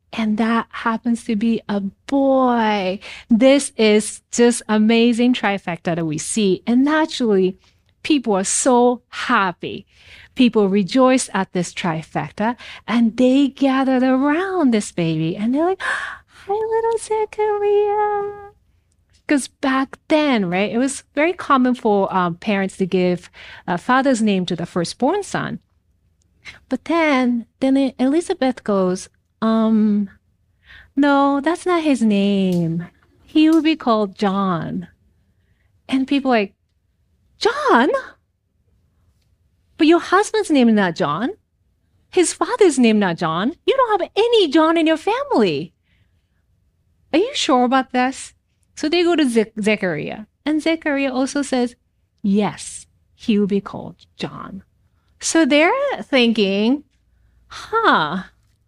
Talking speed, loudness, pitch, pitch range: 130 wpm, -18 LUFS, 240 Hz, 195-295 Hz